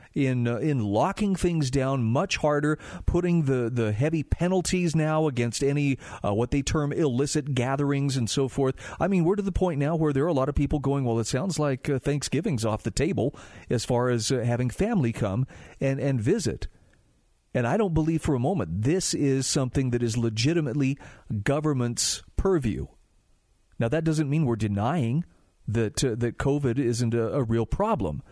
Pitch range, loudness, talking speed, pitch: 120-155 Hz, -26 LUFS, 190 wpm, 135 Hz